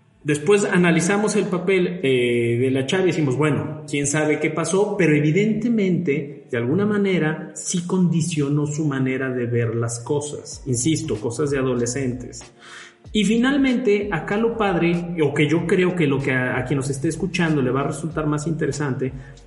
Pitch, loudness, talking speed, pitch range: 155 Hz, -21 LUFS, 175 wpm, 140-180 Hz